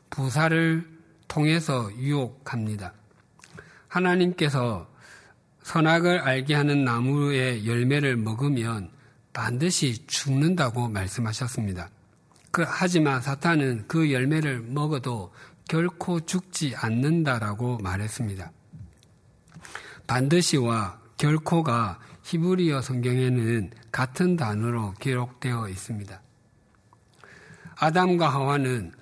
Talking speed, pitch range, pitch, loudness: 220 characters per minute, 115-155 Hz, 130 Hz, -25 LUFS